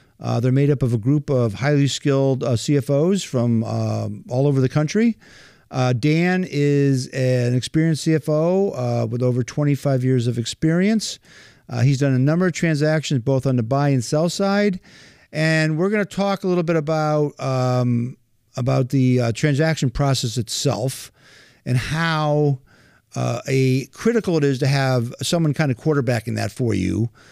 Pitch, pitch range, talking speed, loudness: 140 Hz, 125-155 Hz, 170 wpm, -20 LUFS